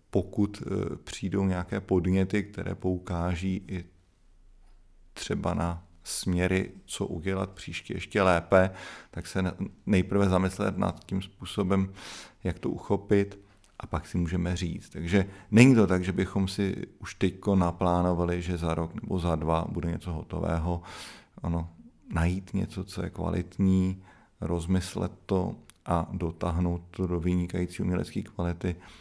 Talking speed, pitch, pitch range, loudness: 130 wpm, 90 Hz, 85-95 Hz, -29 LUFS